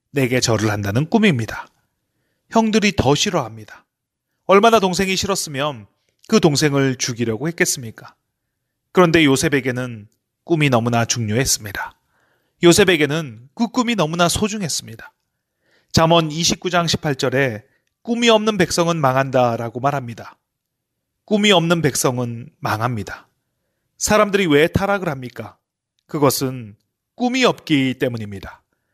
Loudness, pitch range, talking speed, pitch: -17 LUFS, 120-180 Hz, 280 characters per minute, 145 Hz